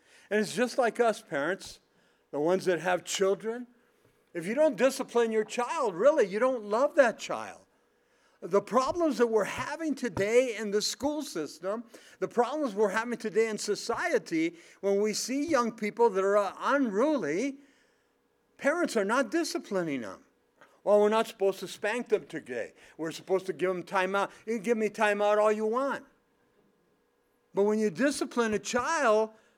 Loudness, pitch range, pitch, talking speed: -29 LUFS, 200-260 Hz, 220 Hz, 170 wpm